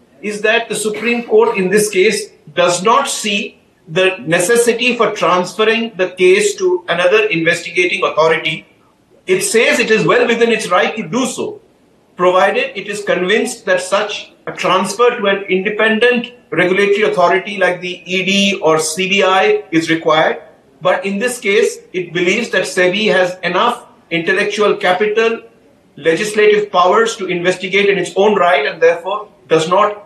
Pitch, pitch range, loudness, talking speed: 200 Hz, 180-230 Hz, -14 LUFS, 150 wpm